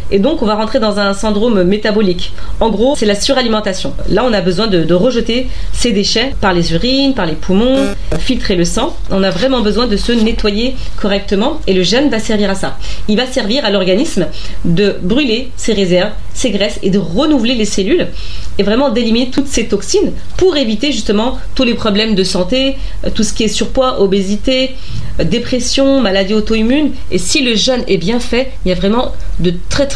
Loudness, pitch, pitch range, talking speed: -13 LUFS, 220 Hz, 195-255 Hz, 200 wpm